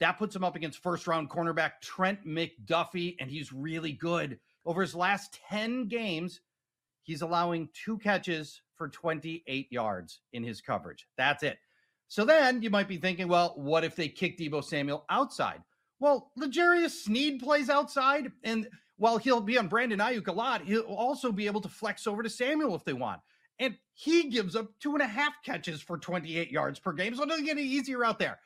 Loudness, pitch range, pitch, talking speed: -31 LUFS, 165-250 Hz, 195 Hz, 195 wpm